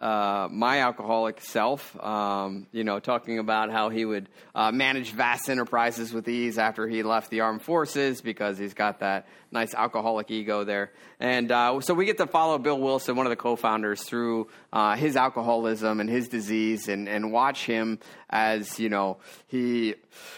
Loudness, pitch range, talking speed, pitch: -27 LUFS, 105-120 Hz, 180 wpm, 110 Hz